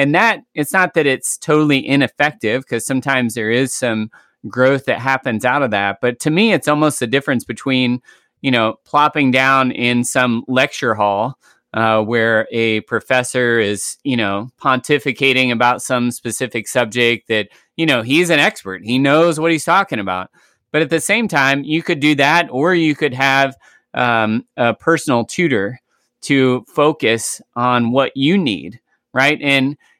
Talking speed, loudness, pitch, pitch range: 170 wpm, -16 LUFS, 130 Hz, 120-145 Hz